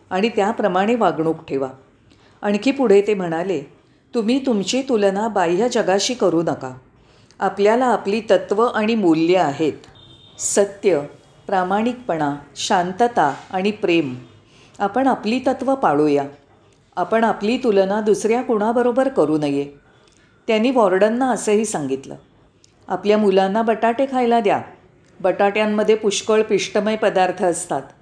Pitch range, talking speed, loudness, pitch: 160-225 Hz, 110 wpm, -19 LUFS, 200 Hz